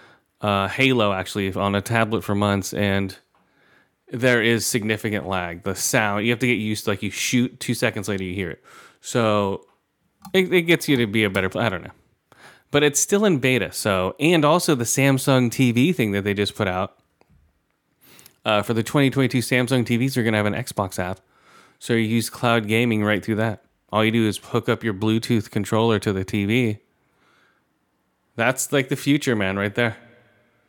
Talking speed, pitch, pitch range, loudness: 195 wpm, 115 Hz, 100-125 Hz, -21 LUFS